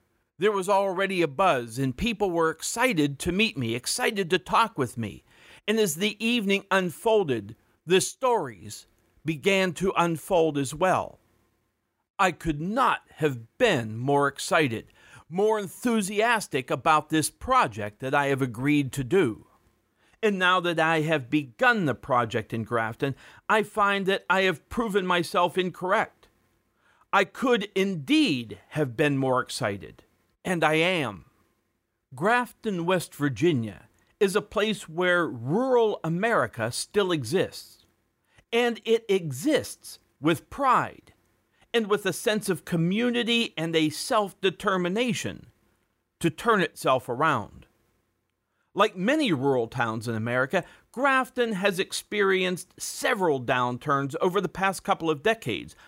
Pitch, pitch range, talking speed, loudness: 175 Hz, 135-205 Hz, 130 wpm, -25 LUFS